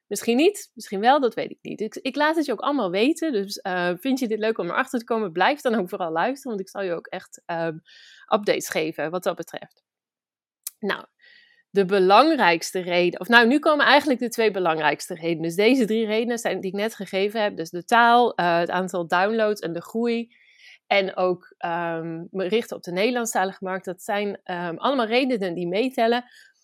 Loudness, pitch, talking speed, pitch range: -23 LUFS, 205 Hz, 205 wpm, 180-240 Hz